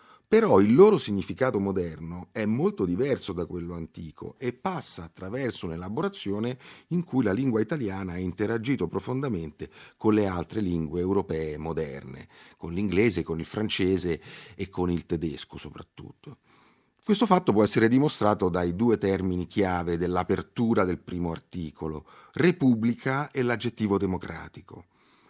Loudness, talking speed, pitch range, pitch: -27 LUFS, 135 wpm, 85-120 Hz, 100 Hz